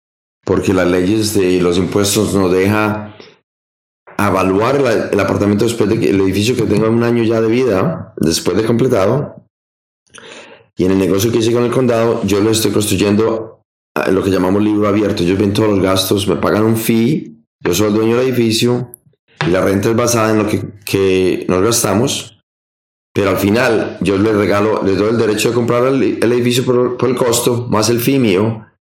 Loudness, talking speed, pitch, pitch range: -14 LUFS, 195 wpm, 105 Hz, 95-115 Hz